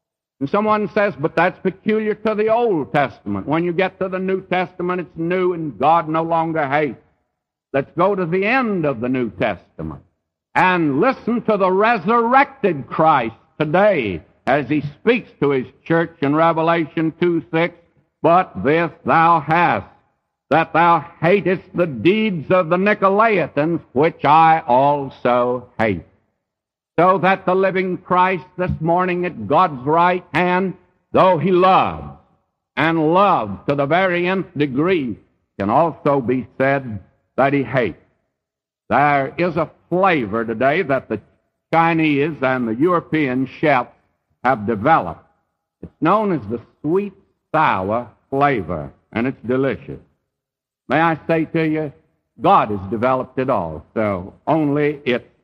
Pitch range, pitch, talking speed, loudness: 140-185 Hz, 165 Hz, 140 wpm, -18 LUFS